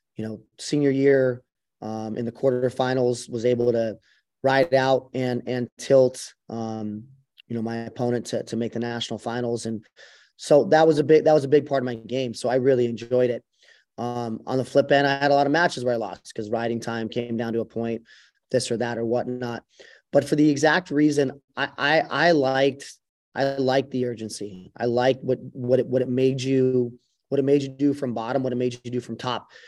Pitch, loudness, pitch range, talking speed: 125 Hz, -23 LUFS, 115-135 Hz, 220 wpm